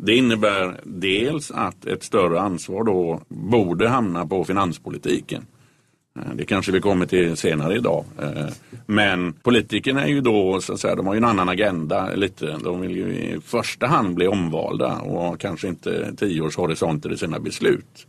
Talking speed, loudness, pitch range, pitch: 160 wpm, -22 LUFS, 90-105 Hz, 95 Hz